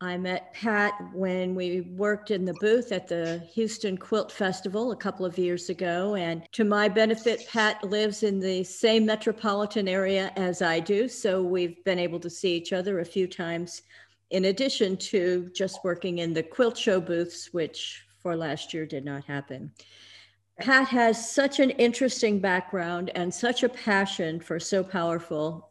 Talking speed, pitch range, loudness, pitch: 175 wpm, 175-215 Hz, -27 LUFS, 190 Hz